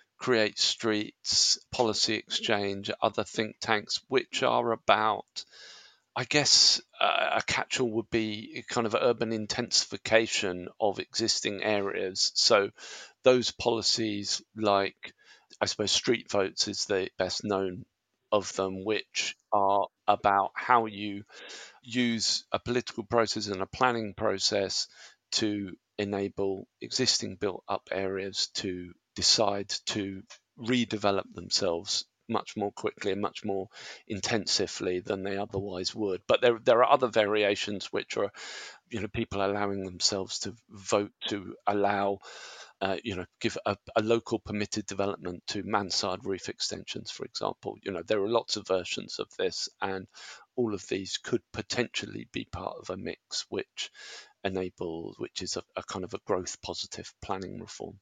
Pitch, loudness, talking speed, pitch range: 100 Hz, -29 LUFS, 145 wpm, 95-110 Hz